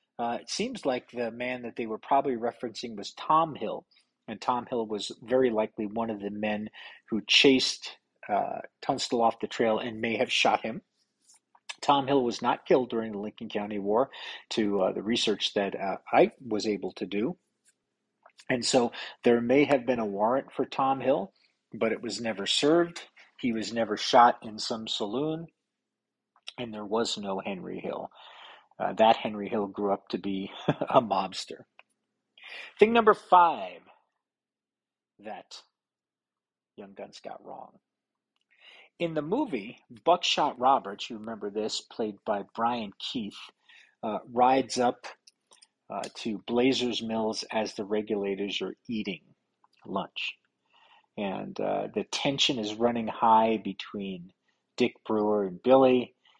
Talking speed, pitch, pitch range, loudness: 150 wpm, 115 Hz, 105-130 Hz, -28 LUFS